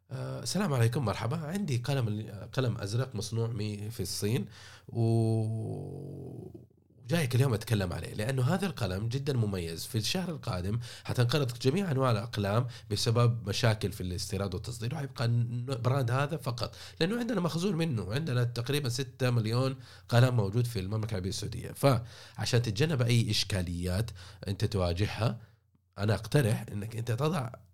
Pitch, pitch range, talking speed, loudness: 120 Hz, 105-130 Hz, 130 wpm, -31 LUFS